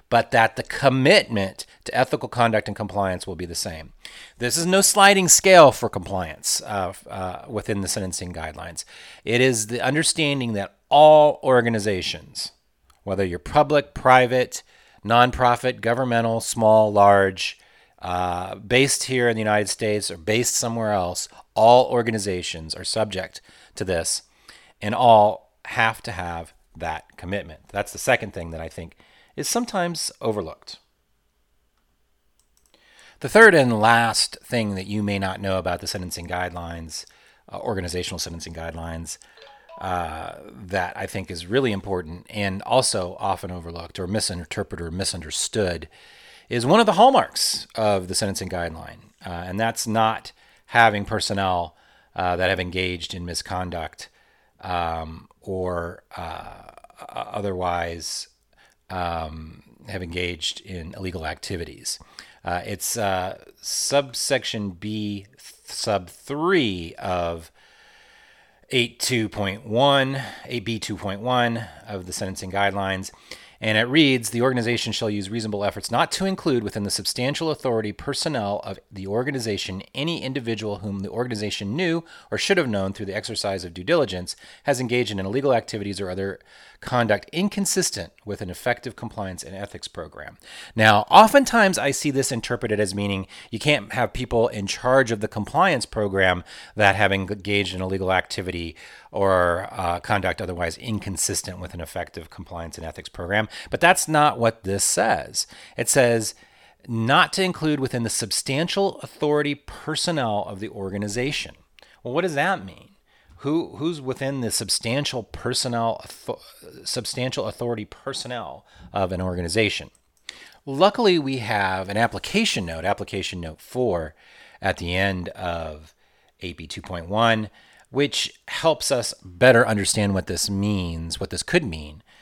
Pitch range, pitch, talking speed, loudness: 90-120 Hz, 105 Hz, 140 wpm, -22 LUFS